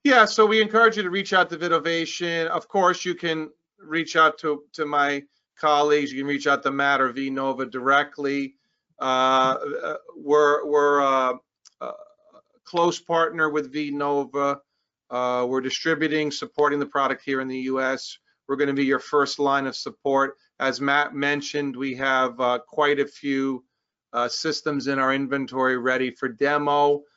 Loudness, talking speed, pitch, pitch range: -23 LUFS, 170 wpm, 145 Hz, 135-155 Hz